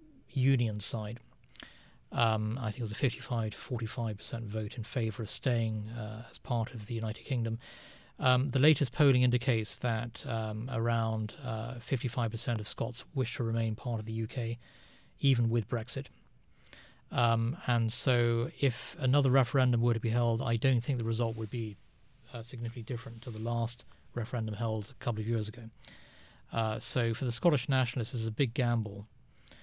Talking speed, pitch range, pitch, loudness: 170 wpm, 110-125 Hz, 115 Hz, -32 LUFS